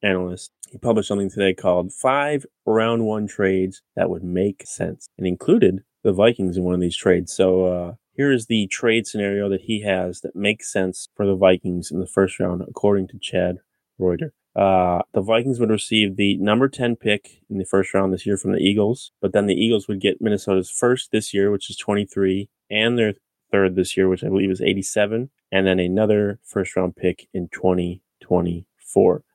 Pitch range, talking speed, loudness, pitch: 95-105 Hz, 195 wpm, -21 LUFS, 100 Hz